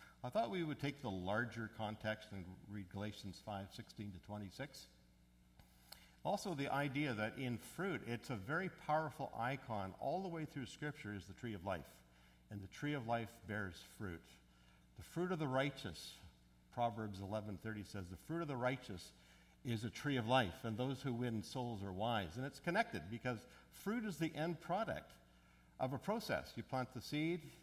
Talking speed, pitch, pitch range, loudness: 185 wpm, 115 Hz, 95-140 Hz, -44 LUFS